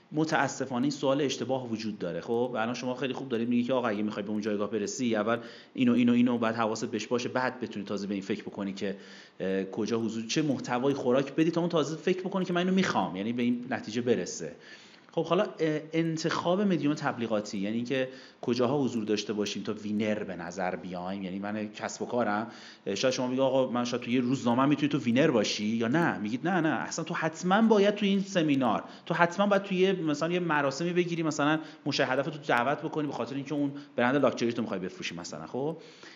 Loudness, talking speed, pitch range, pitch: -29 LUFS, 210 wpm, 110-160 Hz, 130 Hz